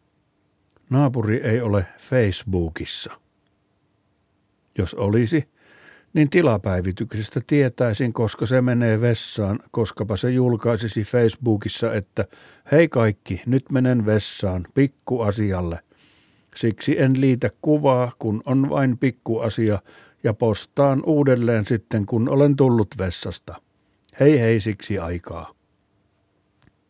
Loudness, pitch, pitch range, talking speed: -21 LUFS, 115 Hz, 100-130 Hz, 100 wpm